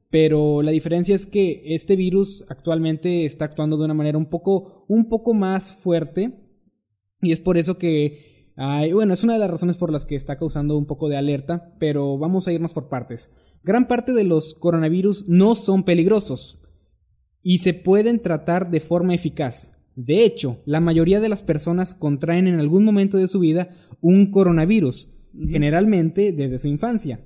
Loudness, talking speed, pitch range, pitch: -20 LUFS, 180 wpm, 150-190 Hz, 170 Hz